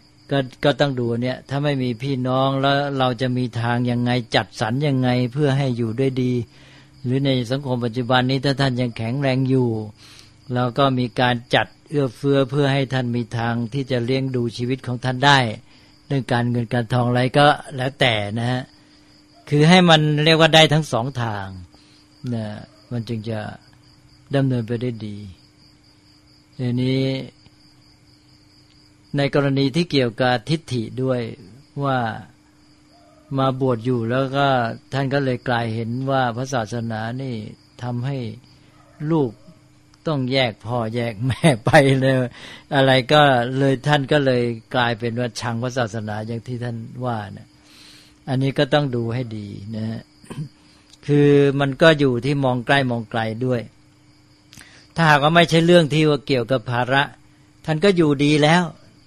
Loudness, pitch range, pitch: -20 LUFS, 120-140 Hz, 130 Hz